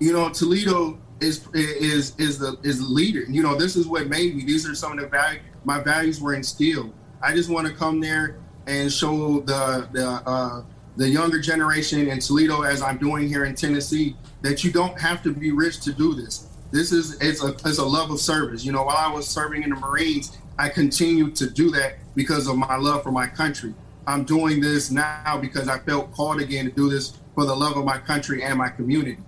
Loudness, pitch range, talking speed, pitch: -22 LUFS, 135-155 Hz, 225 wpm, 145 Hz